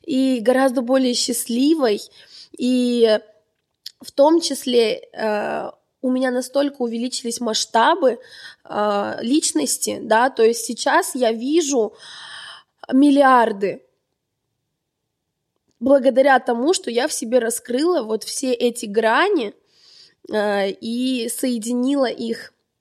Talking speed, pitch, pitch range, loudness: 100 wpm, 250 Hz, 230-275 Hz, -19 LUFS